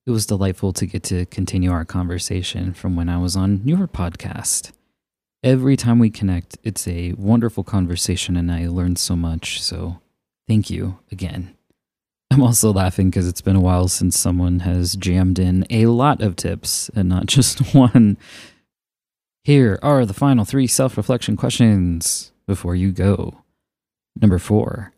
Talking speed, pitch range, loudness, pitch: 160 wpm, 90-115 Hz, -18 LUFS, 95 Hz